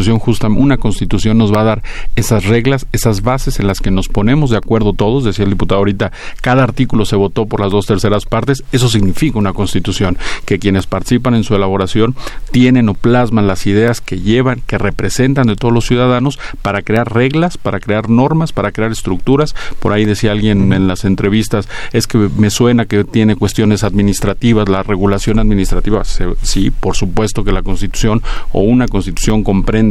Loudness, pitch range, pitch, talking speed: -13 LUFS, 100-120 Hz, 110 Hz, 185 wpm